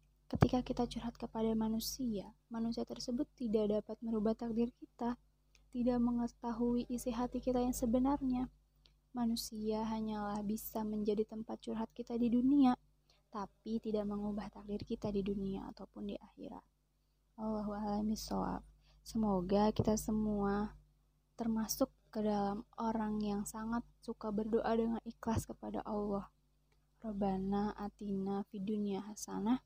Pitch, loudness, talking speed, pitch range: 220 Hz, -38 LUFS, 115 wpm, 205-235 Hz